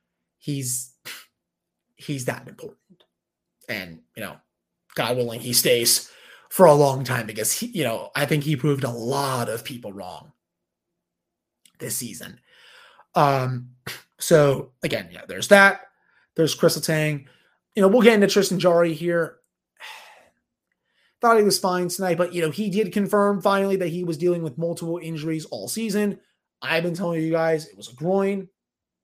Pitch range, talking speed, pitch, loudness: 135-190 Hz, 160 wpm, 165 Hz, -21 LUFS